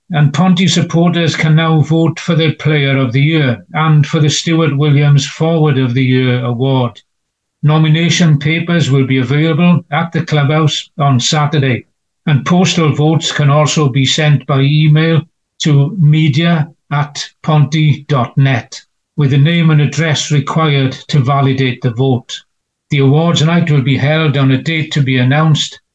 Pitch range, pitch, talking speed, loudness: 140-160 Hz, 150 Hz, 155 wpm, -12 LUFS